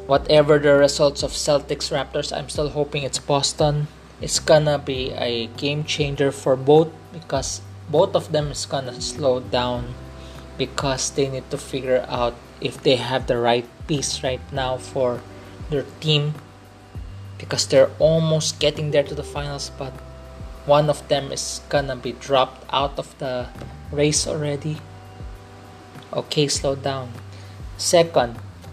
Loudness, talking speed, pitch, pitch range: -21 LUFS, 145 wpm, 130 Hz, 100-145 Hz